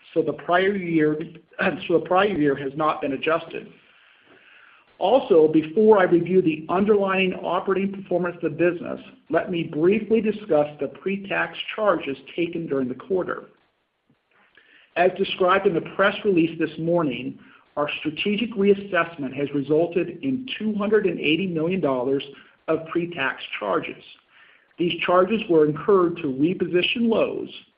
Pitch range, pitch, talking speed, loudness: 155-195 Hz, 170 Hz, 130 wpm, -22 LUFS